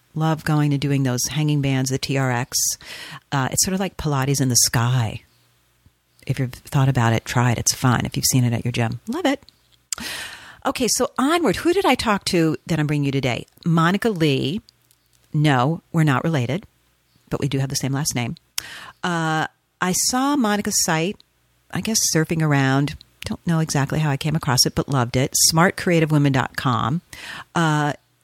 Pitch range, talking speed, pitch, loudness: 125-165 Hz, 180 wpm, 145 Hz, -20 LUFS